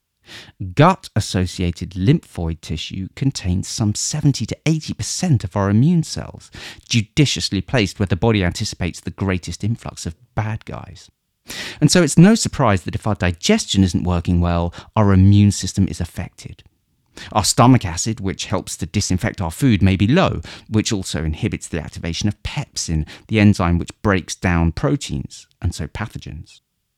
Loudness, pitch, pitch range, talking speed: -19 LUFS, 100 Hz, 90-115 Hz, 160 wpm